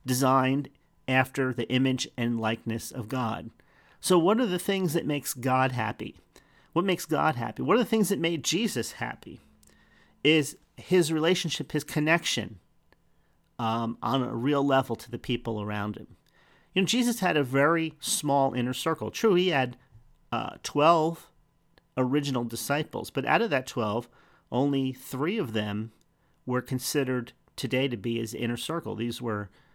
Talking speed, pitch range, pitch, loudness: 160 wpm, 115-155 Hz, 130 Hz, -27 LUFS